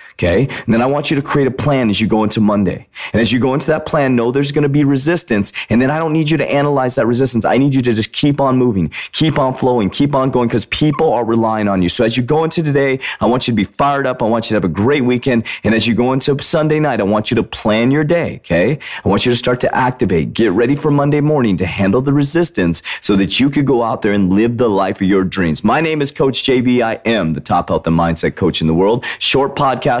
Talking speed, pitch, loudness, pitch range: 285 wpm, 125 Hz, -14 LUFS, 105-140 Hz